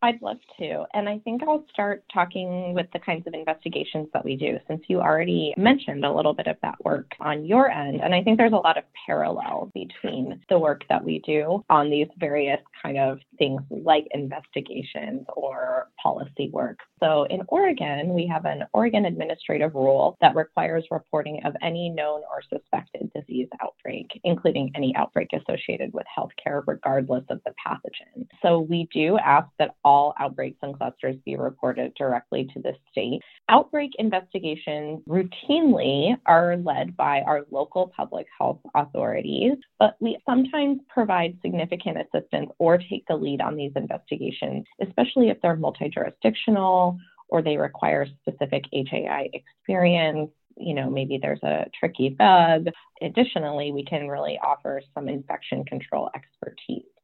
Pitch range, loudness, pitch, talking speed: 145-210 Hz, -24 LUFS, 170 Hz, 160 wpm